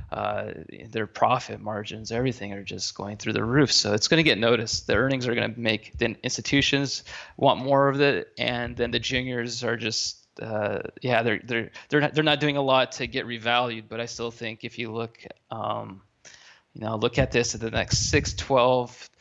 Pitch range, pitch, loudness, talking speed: 110-125 Hz, 120 Hz, -25 LUFS, 210 wpm